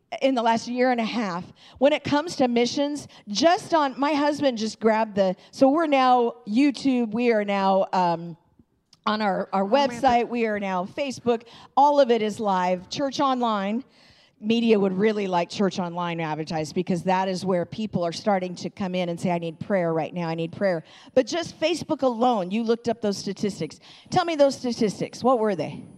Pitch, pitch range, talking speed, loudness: 220 Hz, 185-260 Hz, 195 wpm, -24 LUFS